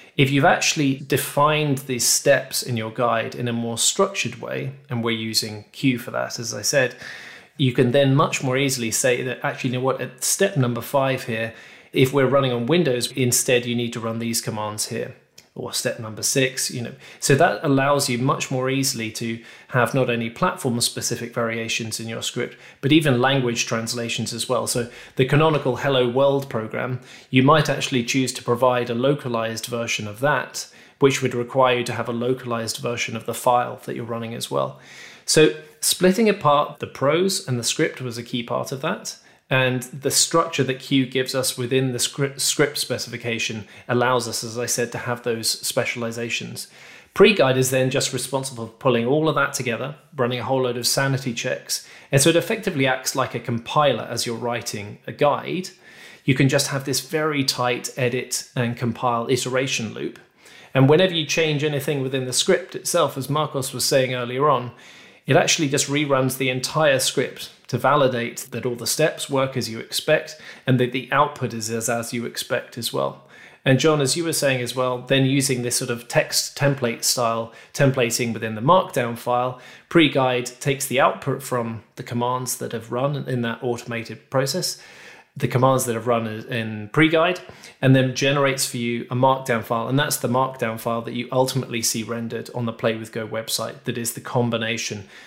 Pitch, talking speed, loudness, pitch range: 125 Hz, 195 wpm, -21 LUFS, 120-135 Hz